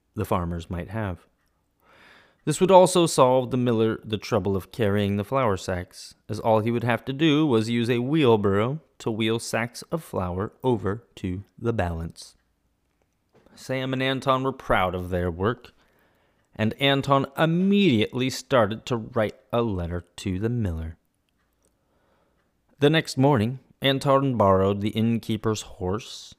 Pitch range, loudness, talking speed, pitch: 95-135 Hz, -24 LUFS, 145 wpm, 115 Hz